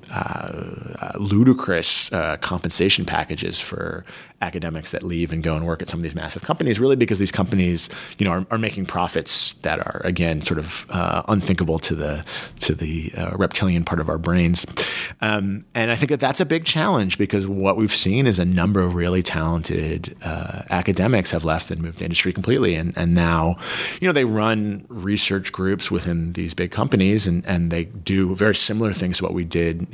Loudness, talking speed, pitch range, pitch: -20 LUFS, 200 wpm, 85-105 Hz, 95 Hz